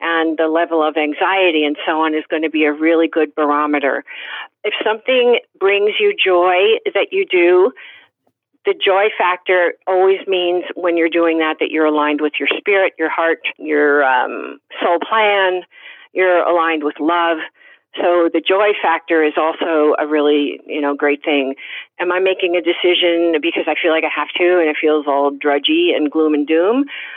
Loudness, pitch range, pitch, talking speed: -15 LUFS, 155-190 Hz, 165 Hz, 180 wpm